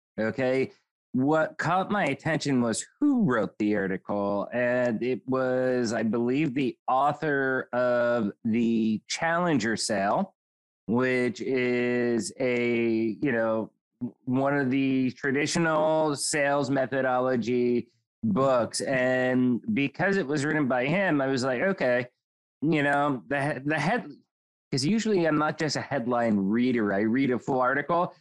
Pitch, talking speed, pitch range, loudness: 130 Hz, 130 wpm, 120-145 Hz, -26 LUFS